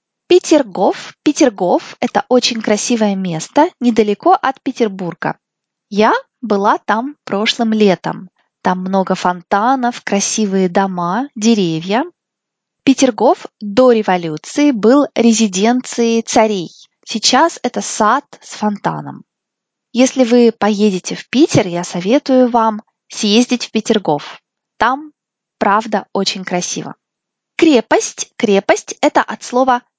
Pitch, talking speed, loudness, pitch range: 225 Hz, 100 wpm, -14 LUFS, 200-260 Hz